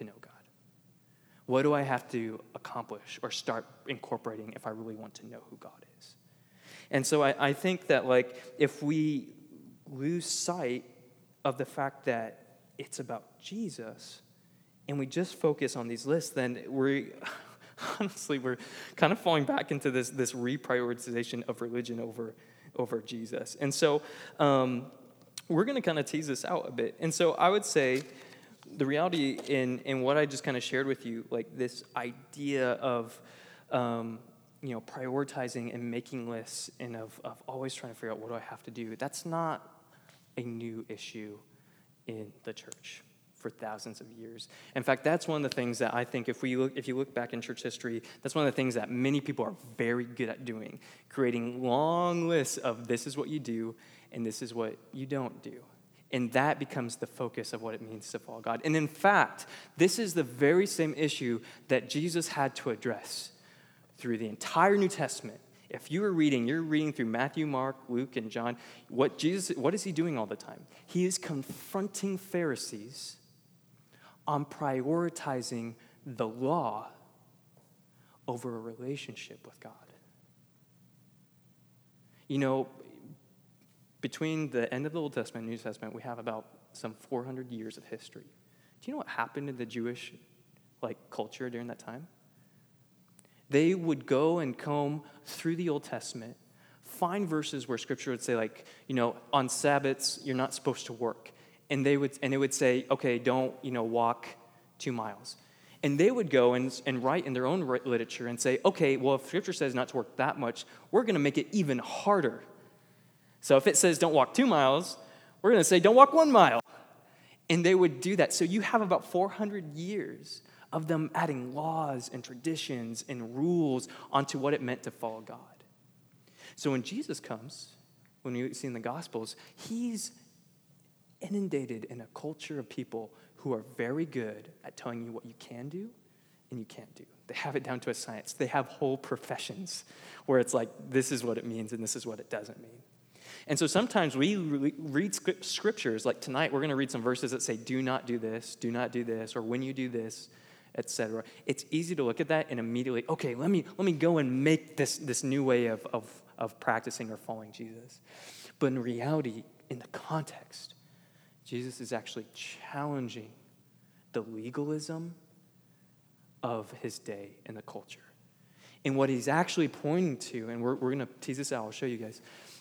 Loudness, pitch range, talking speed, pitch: -32 LUFS, 120-155 Hz, 185 wpm, 130 Hz